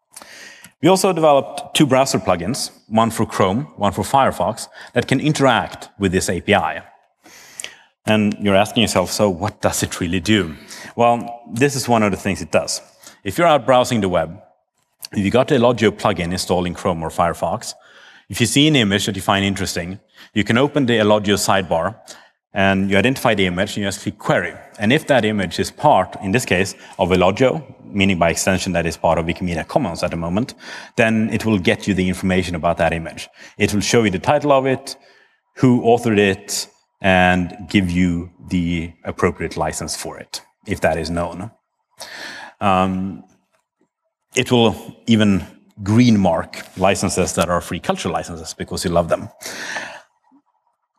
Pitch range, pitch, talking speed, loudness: 95-120 Hz, 105 Hz, 180 wpm, -18 LUFS